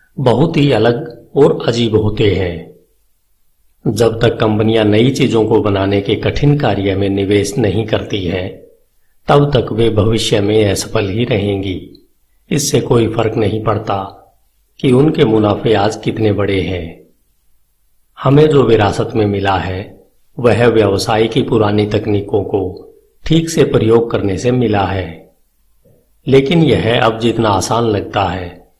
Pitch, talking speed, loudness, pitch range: 110 Hz, 145 wpm, -13 LUFS, 100-120 Hz